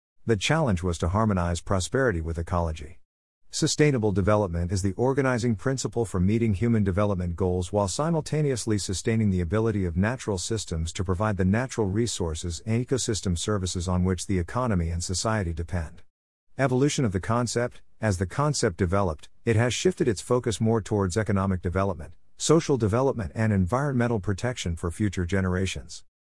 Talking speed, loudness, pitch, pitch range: 155 wpm, -26 LUFS, 100 Hz, 90-115 Hz